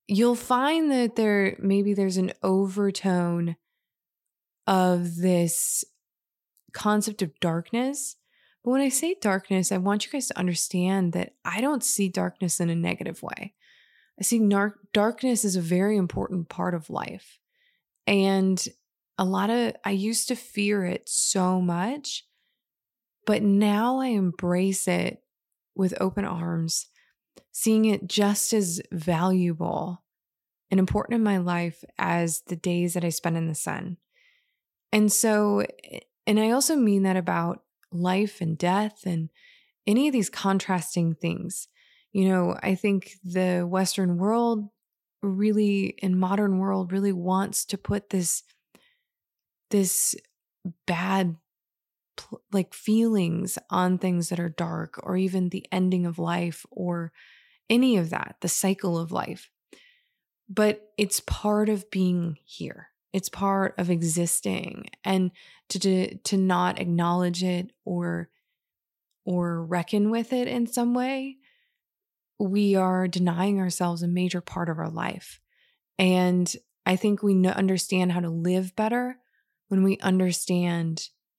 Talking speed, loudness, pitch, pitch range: 135 wpm, -25 LUFS, 190 Hz, 180-210 Hz